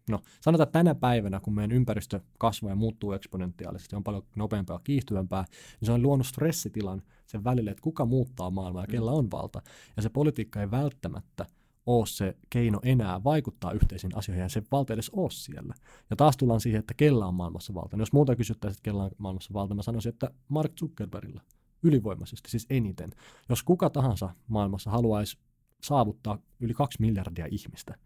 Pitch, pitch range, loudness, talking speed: 110 Hz, 100-130 Hz, -29 LUFS, 185 wpm